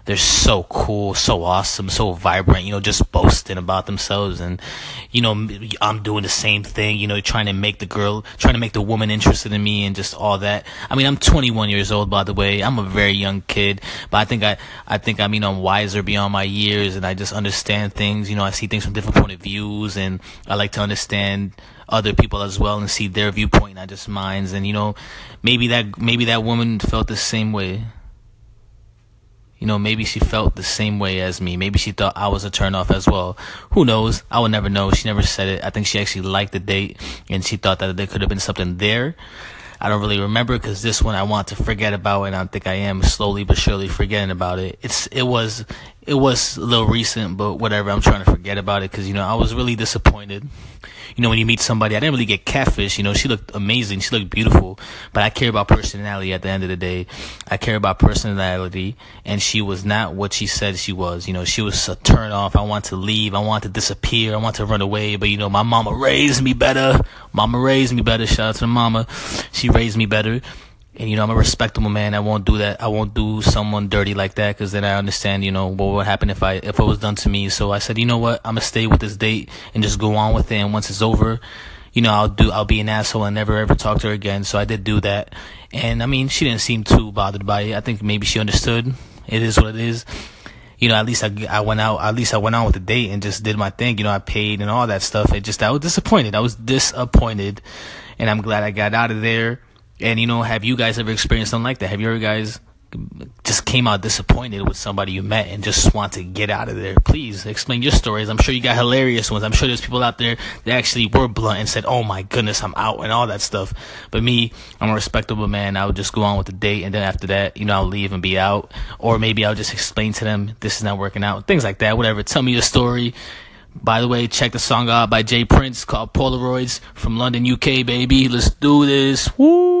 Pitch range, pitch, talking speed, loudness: 100-115 Hz, 105 Hz, 255 wpm, -18 LUFS